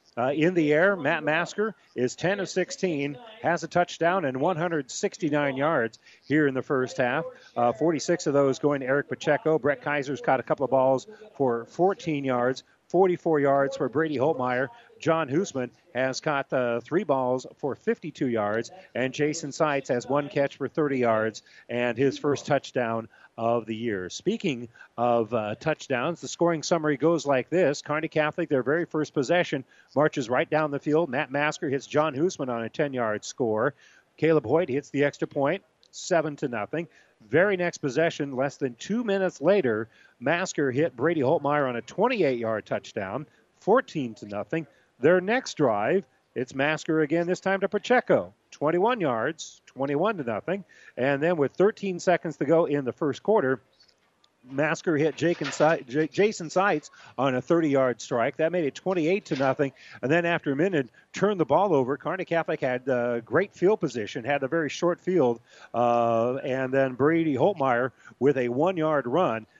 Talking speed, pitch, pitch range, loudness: 175 wpm, 150 Hz, 130-170 Hz, -26 LUFS